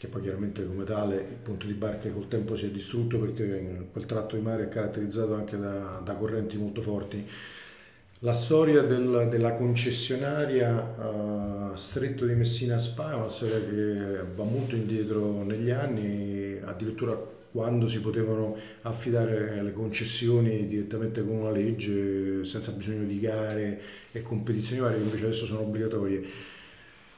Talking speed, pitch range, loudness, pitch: 150 wpm, 105-115 Hz, -30 LUFS, 110 Hz